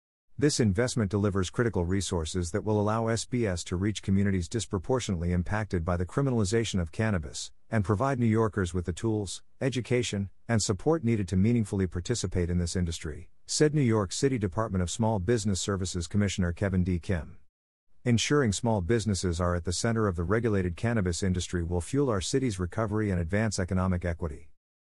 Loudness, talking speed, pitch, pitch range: -29 LUFS, 170 wpm, 100 Hz, 90-115 Hz